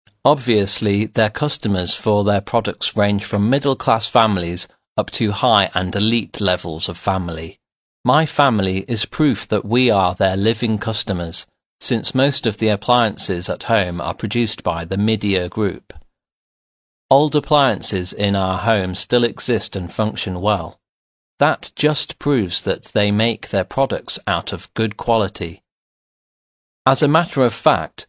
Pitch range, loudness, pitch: 95-120 Hz, -18 LUFS, 105 Hz